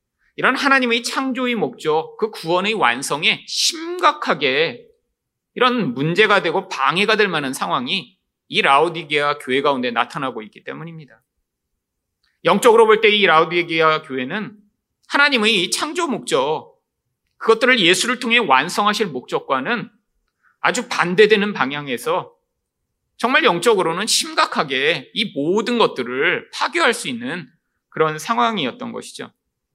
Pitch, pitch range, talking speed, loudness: 220 Hz, 160-255 Hz, 290 characters per minute, -17 LUFS